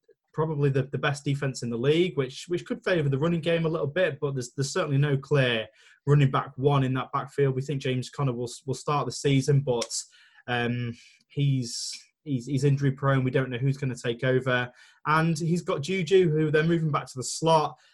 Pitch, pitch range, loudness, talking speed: 140 Hz, 130-155 Hz, -26 LUFS, 215 wpm